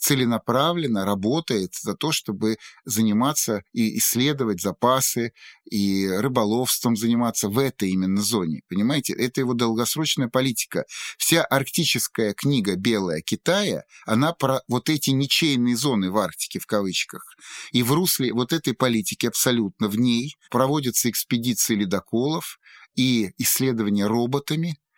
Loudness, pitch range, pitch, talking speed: -22 LUFS, 110-135 Hz, 120 Hz, 125 wpm